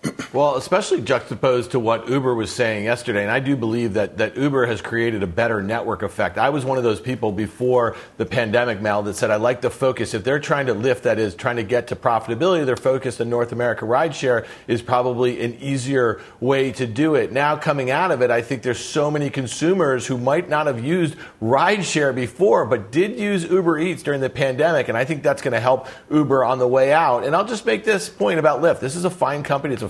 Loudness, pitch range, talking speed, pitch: -20 LUFS, 120-145 Hz, 235 wpm, 130 Hz